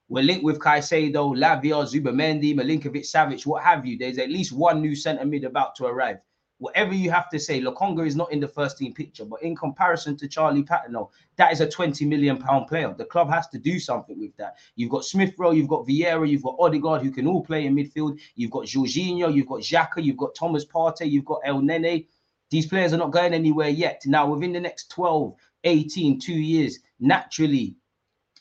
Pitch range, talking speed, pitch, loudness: 145-170 Hz, 210 wpm, 155 Hz, -23 LUFS